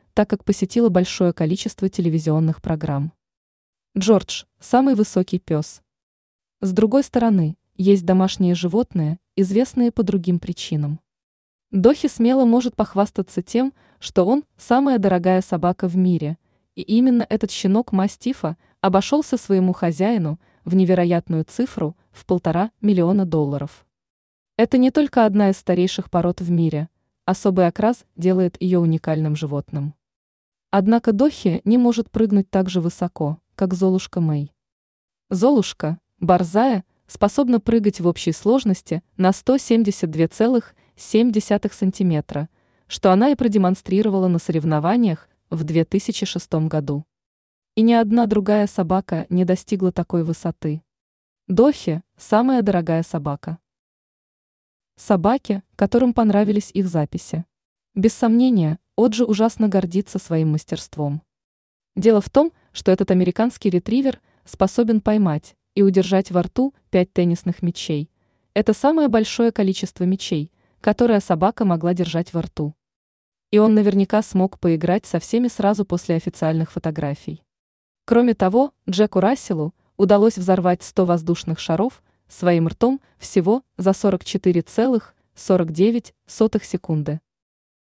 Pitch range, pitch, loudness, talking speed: 170-220 Hz, 190 Hz, -20 LUFS, 115 wpm